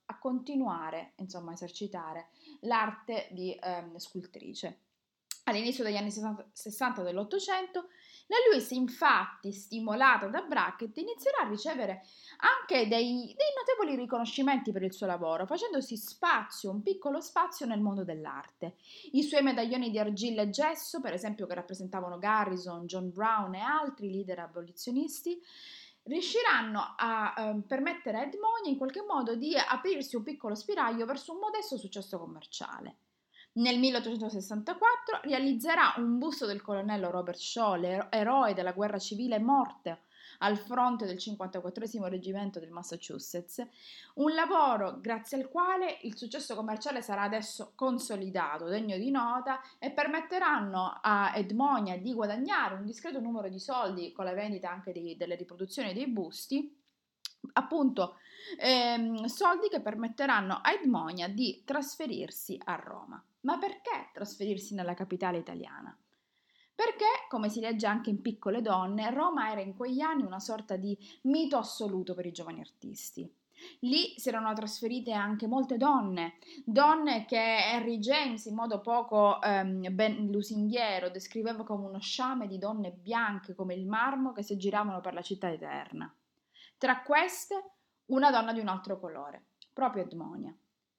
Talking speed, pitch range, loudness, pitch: 140 wpm, 195-275 Hz, -32 LUFS, 225 Hz